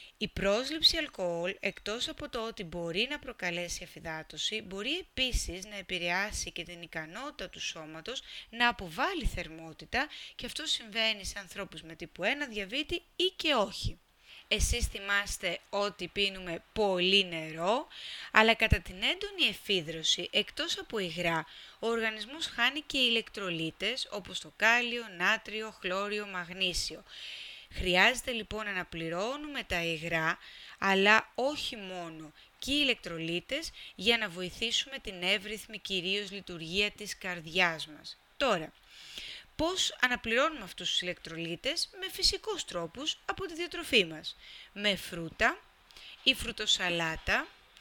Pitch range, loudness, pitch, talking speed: 175-250 Hz, -31 LUFS, 205 Hz, 125 wpm